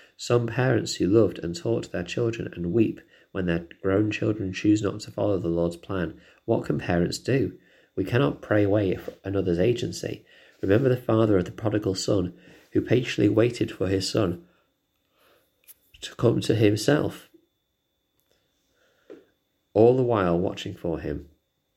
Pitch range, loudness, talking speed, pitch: 95-115 Hz, -25 LUFS, 150 wpm, 105 Hz